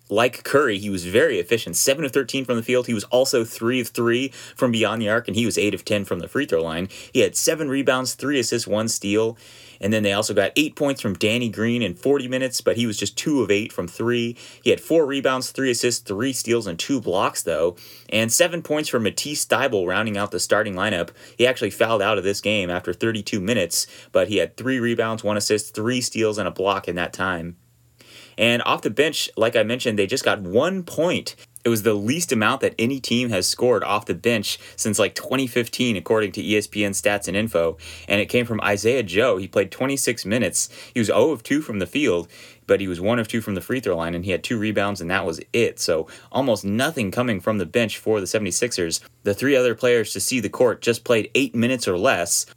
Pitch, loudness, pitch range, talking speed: 115 Hz, -21 LUFS, 105-125 Hz, 235 wpm